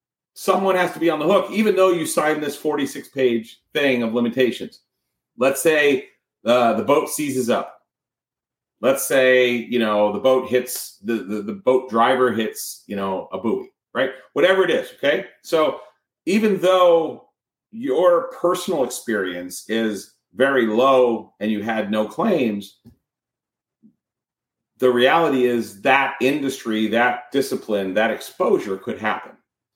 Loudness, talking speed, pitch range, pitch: -20 LUFS, 140 wpm, 110-150 Hz, 125 Hz